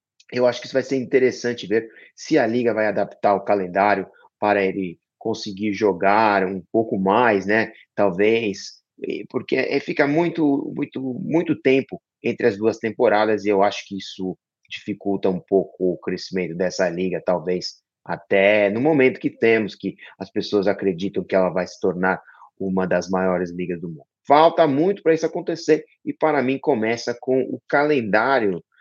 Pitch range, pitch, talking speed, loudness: 95-130 Hz, 105 Hz, 165 wpm, -21 LUFS